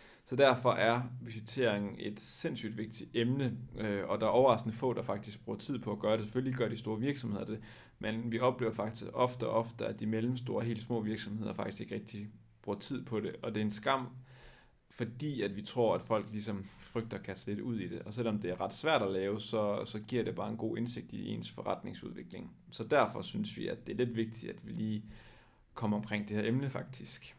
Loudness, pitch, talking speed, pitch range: -36 LUFS, 110 Hz, 230 wpm, 105-120 Hz